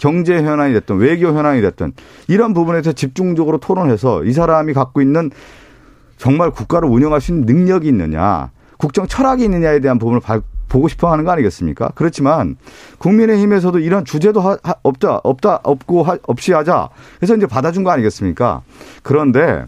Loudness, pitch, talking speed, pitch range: -14 LUFS, 155 Hz, 385 characters per minute, 130-180 Hz